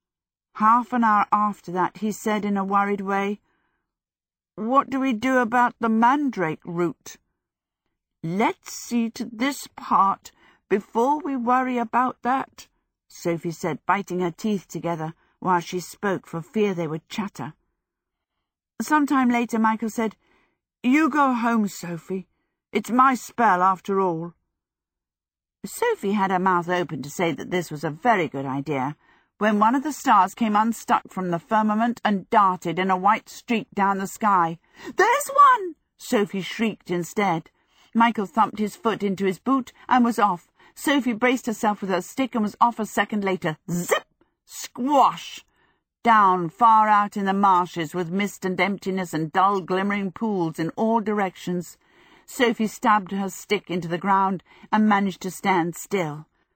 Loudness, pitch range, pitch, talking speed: -23 LUFS, 180-235 Hz, 205 Hz, 155 wpm